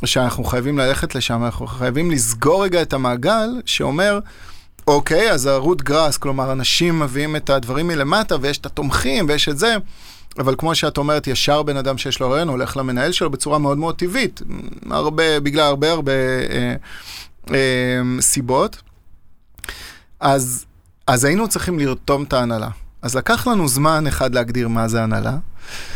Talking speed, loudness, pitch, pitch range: 155 wpm, -18 LUFS, 135 Hz, 125-155 Hz